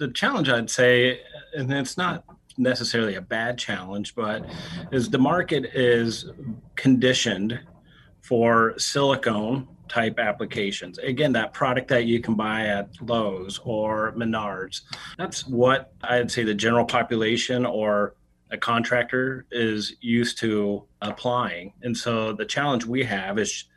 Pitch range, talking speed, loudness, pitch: 110-125 Hz, 135 wpm, -24 LUFS, 120 Hz